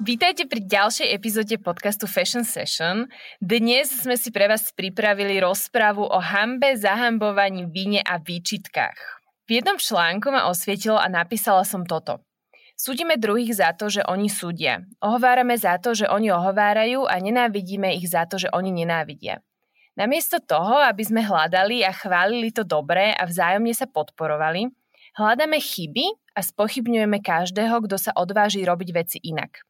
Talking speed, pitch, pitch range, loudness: 150 wpm, 205 Hz, 180-235 Hz, -21 LUFS